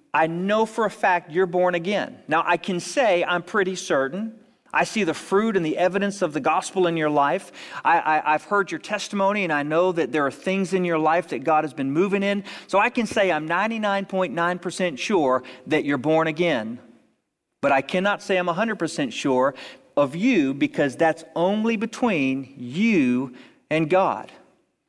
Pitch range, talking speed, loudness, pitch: 155-200 Hz, 185 wpm, -22 LUFS, 180 Hz